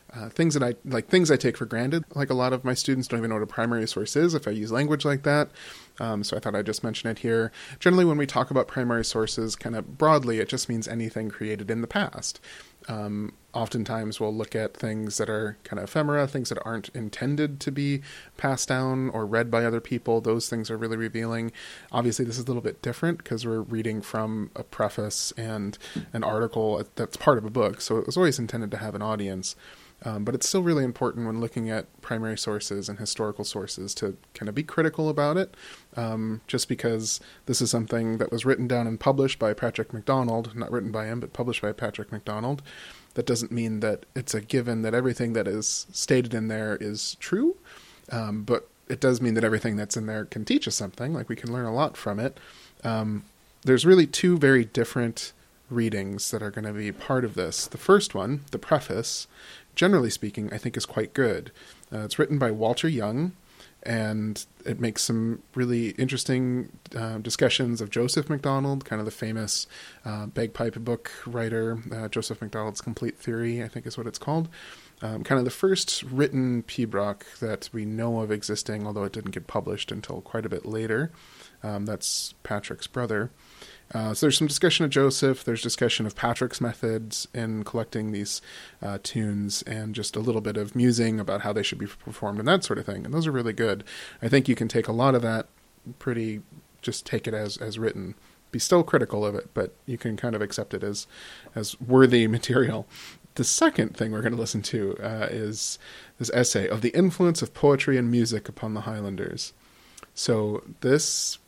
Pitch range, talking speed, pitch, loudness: 110-130 Hz, 205 wpm, 115 Hz, -27 LUFS